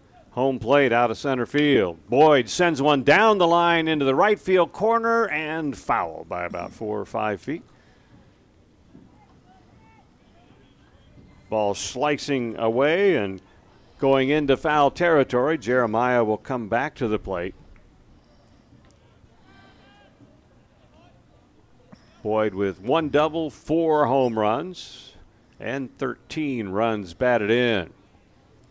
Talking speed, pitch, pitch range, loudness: 110 wpm, 130 Hz, 110-150 Hz, -22 LUFS